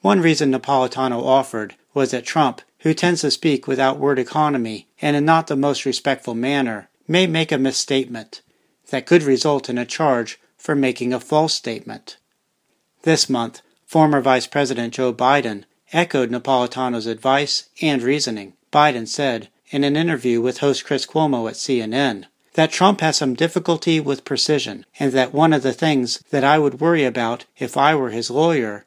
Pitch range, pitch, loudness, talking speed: 125-155 Hz, 135 Hz, -19 LUFS, 170 wpm